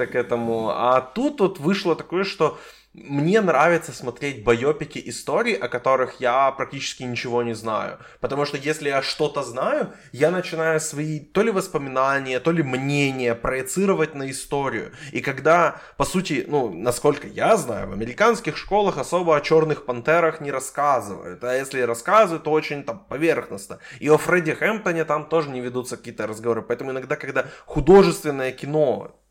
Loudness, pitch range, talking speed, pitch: -22 LUFS, 130-160 Hz, 160 wpm, 145 Hz